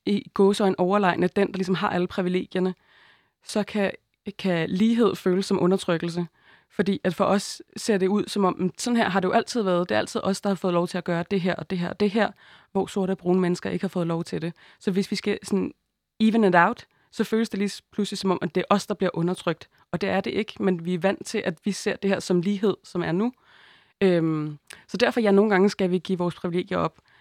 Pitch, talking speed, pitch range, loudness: 190 Hz, 260 wpm, 180-205 Hz, -25 LUFS